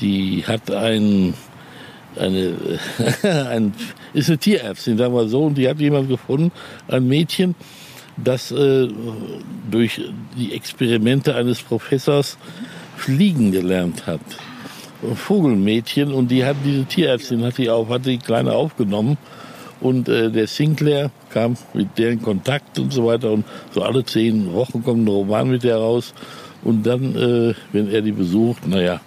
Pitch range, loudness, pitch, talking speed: 110-140 Hz, -19 LUFS, 120 Hz, 155 wpm